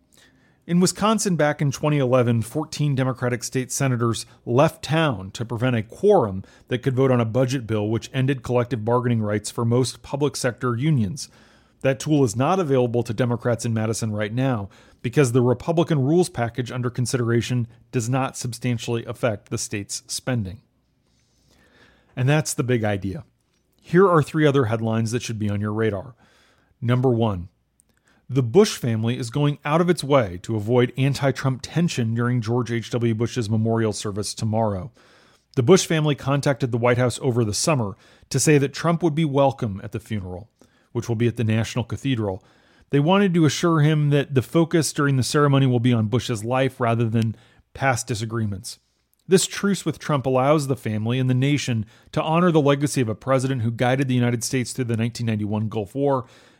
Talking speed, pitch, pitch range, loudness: 180 wpm, 125 Hz, 115-140 Hz, -22 LUFS